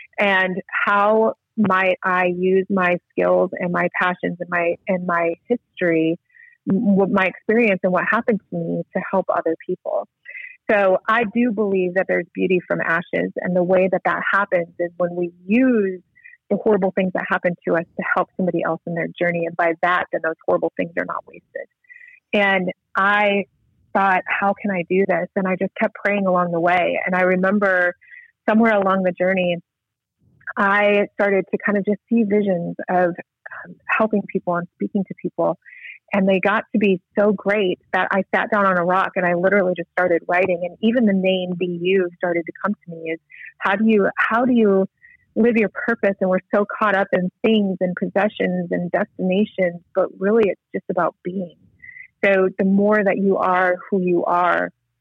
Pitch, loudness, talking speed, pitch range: 190 Hz, -20 LUFS, 190 wpm, 175-205 Hz